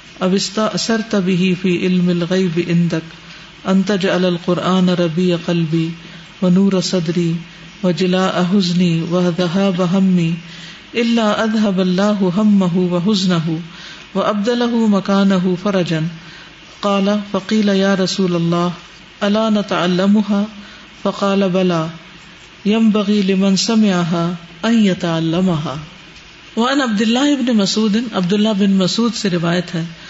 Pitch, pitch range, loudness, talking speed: 185 Hz, 175-205 Hz, -16 LUFS, 110 wpm